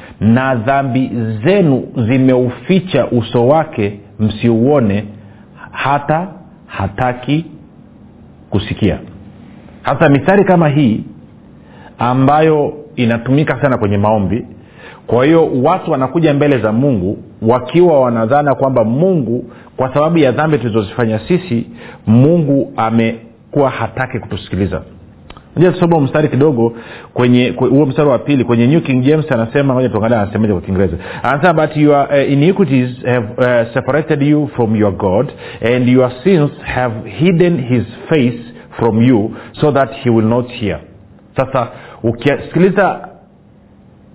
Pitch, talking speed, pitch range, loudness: 125 Hz, 115 wpm, 115-145 Hz, -13 LUFS